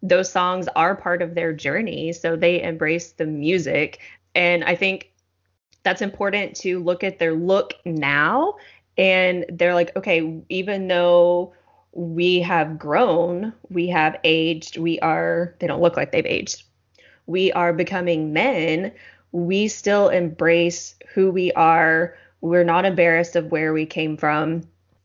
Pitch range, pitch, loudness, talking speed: 165-180 Hz, 175 Hz, -20 LUFS, 145 wpm